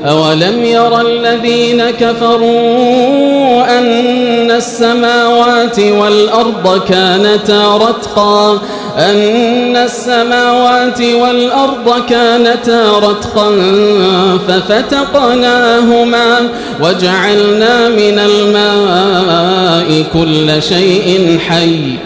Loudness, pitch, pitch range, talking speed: -9 LUFS, 230 Hz, 200-240 Hz, 55 wpm